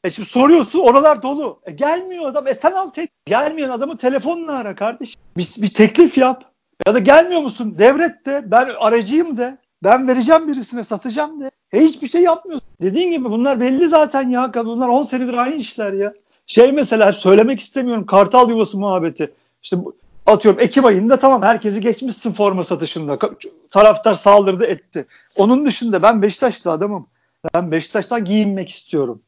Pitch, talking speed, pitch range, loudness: 245 Hz, 165 wpm, 205-280 Hz, -15 LUFS